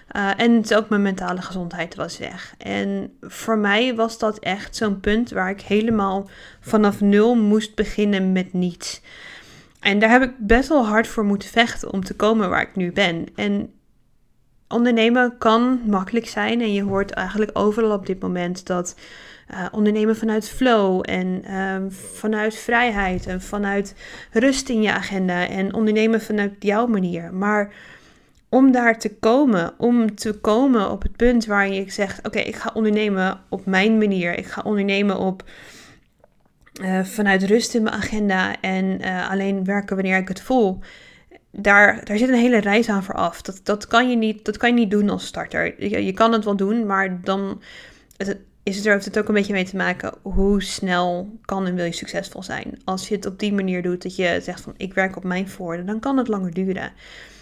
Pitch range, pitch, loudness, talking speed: 190-220 Hz, 205 Hz, -20 LUFS, 190 wpm